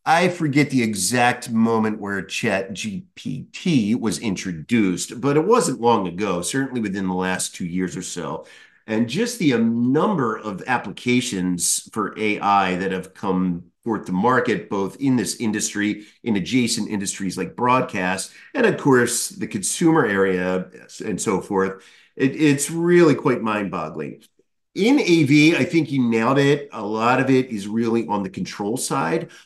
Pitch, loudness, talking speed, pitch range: 115 Hz, -21 LUFS, 160 wpm, 95-135 Hz